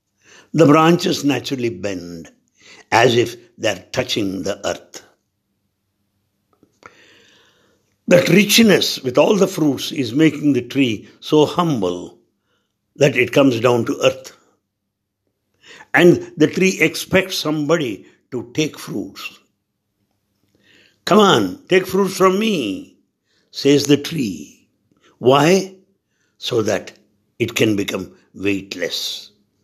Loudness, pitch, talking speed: -17 LUFS, 140 Hz, 105 wpm